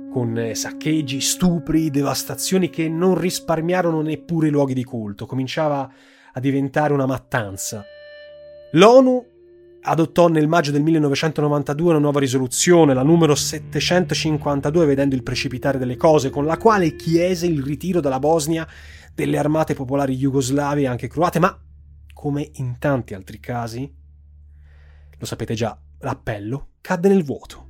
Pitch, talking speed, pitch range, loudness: 145 Hz, 135 wpm, 130-165 Hz, -19 LUFS